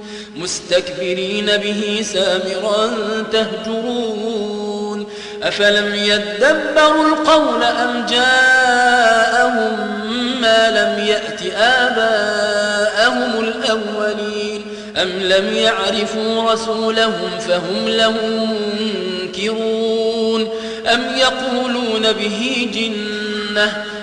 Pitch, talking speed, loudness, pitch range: 220 Hz, 60 wpm, -16 LUFS, 210-225 Hz